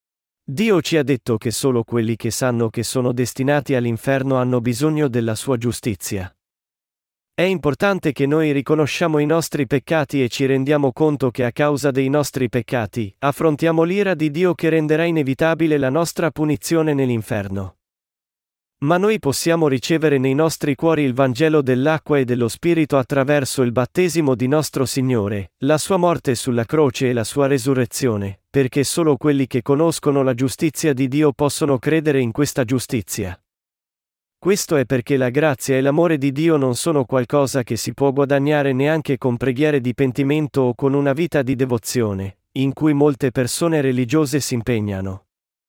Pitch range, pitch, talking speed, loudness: 125-155 Hz, 140 Hz, 160 wpm, -19 LUFS